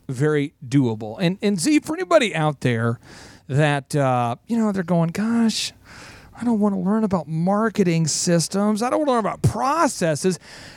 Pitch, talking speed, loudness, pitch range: 170 Hz, 175 wpm, -21 LUFS, 145-215 Hz